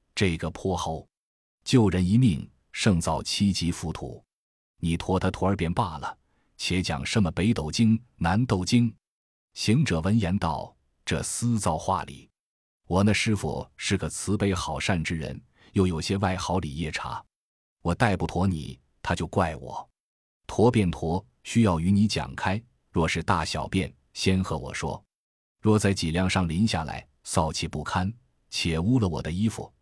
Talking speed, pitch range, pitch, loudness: 215 characters per minute, 80-105 Hz, 90 Hz, -26 LUFS